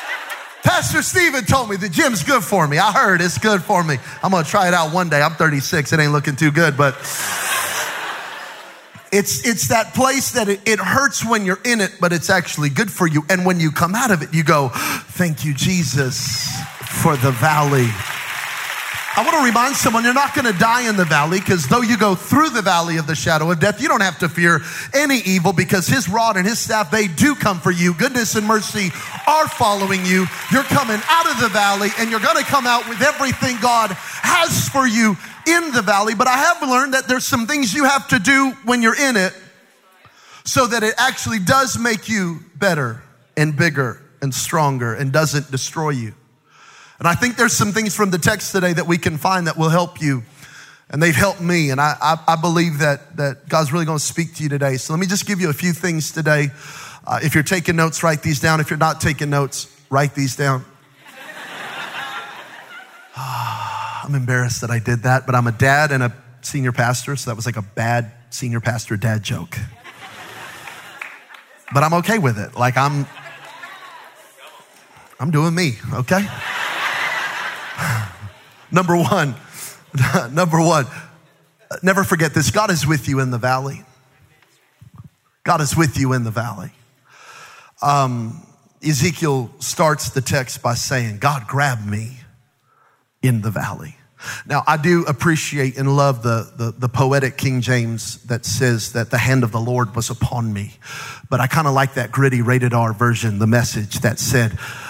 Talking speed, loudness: 190 wpm, -17 LUFS